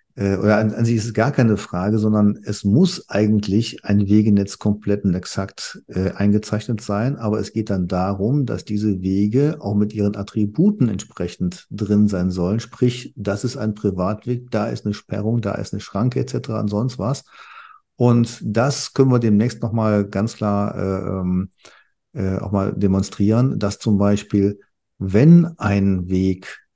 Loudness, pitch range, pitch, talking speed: -20 LUFS, 100-115 Hz, 105 Hz, 165 wpm